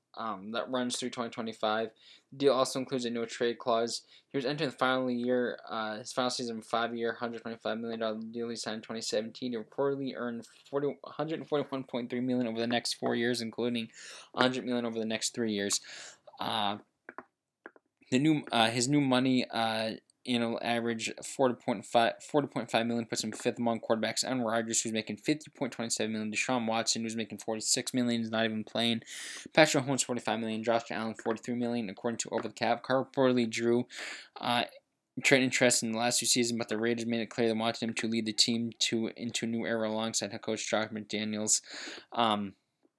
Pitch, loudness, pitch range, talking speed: 115 Hz, -31 LUFS, 110-125 Hz, 190 wpm